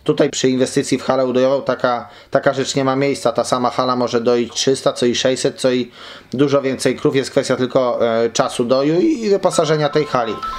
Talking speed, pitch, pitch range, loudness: 210 wpm, 130 Hz, 125-140 Hz, -17 LUFS